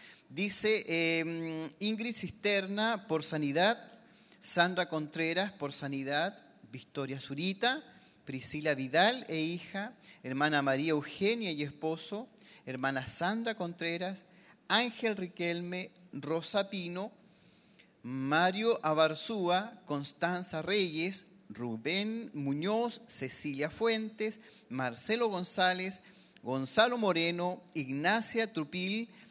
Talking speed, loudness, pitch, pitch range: 85 wpm, -32 LUFS, 180 Hz, 155-215 Hz